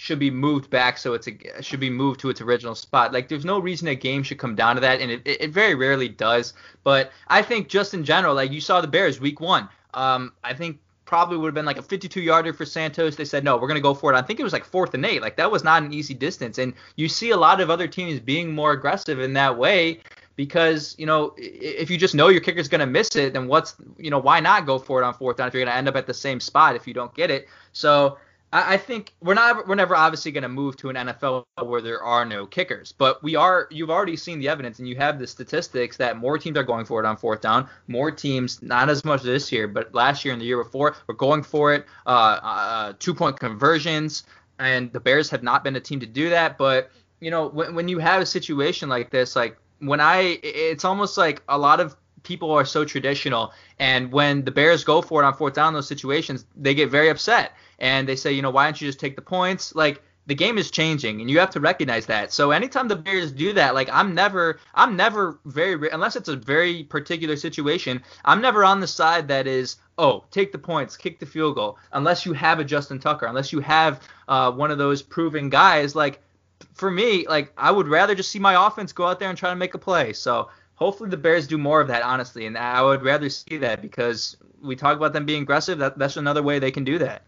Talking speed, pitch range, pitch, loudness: 255 wpm, 130-165 Hz, 145 Hz, -21 LUFS